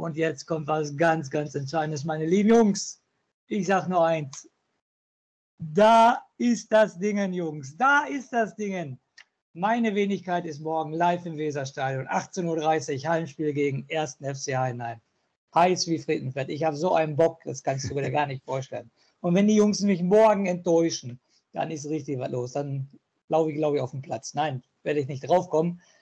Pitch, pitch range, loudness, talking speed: 160 Hz, 145-185 Hz, -25 LUFS, 180 wpm